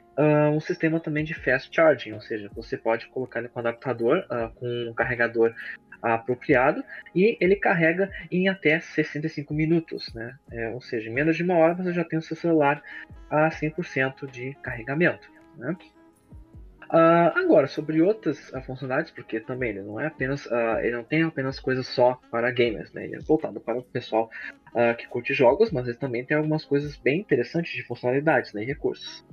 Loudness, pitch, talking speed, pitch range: -25 LUFS, 140 Hz, 190 wpm, 120-160 Hz